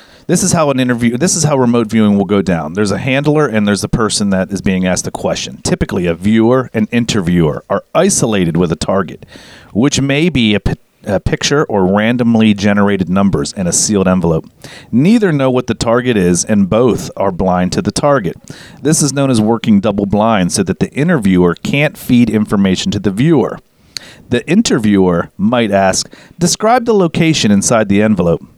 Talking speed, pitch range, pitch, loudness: 190 wpm, 100-140 Hz, 110 Hz, -12 LUFS